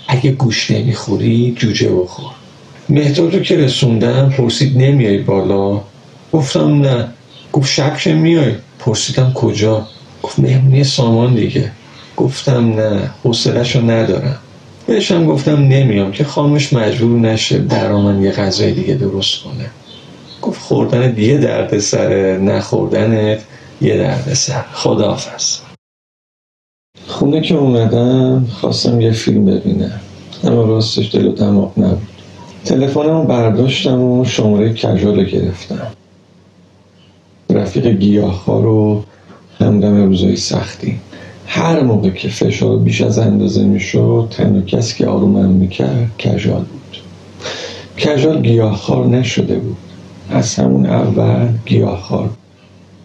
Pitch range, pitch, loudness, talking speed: 100-135 Hz, 115 Hz, -13 LUFS, 120 wpm